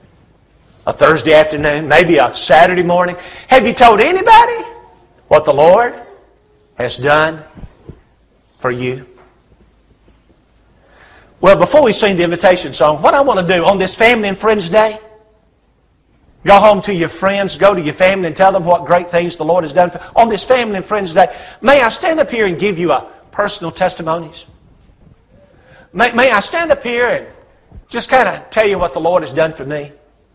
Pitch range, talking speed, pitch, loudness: 160-220 Hz, 180 wpm, 185 Hz, -12 LUFS